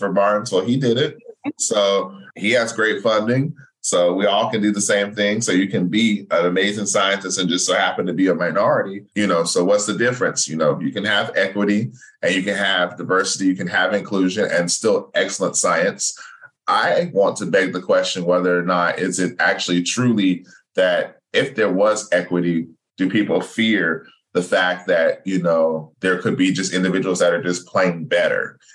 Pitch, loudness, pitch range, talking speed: 95 Hz, -19 LUFS, 90-105 Hz, 200 wpm